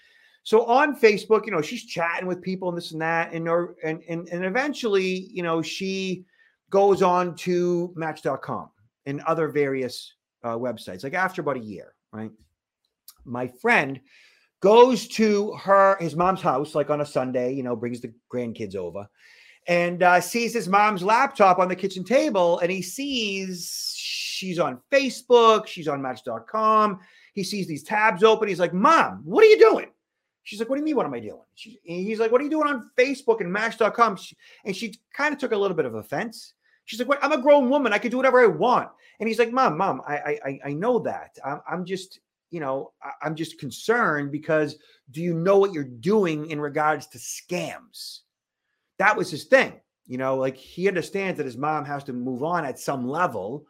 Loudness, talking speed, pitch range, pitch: -23 LUFS, 195 wpm, 150-220 Hz, 180 Hz